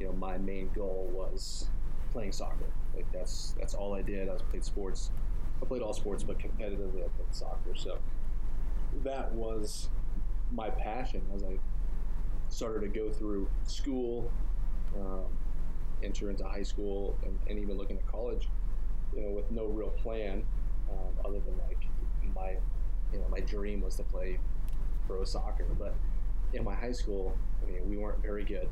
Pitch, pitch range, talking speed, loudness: 95 Hz, 90-105 Hz, 170 wpm, -38 LUFS